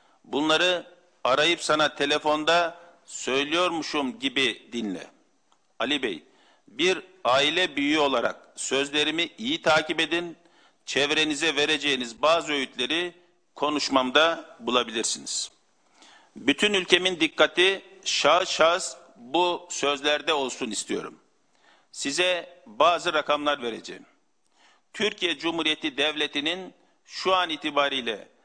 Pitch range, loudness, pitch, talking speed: 150-180 Hz, -24 LUFS, 165 Hz, 90 wpm